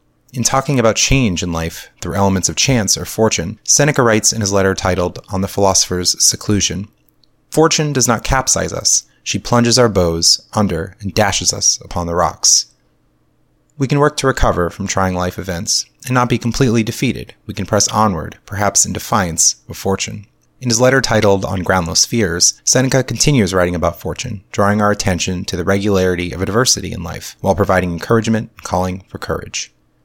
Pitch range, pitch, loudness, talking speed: 90-115 Hz, 100 Hz, -15 LUFS, 180 wpm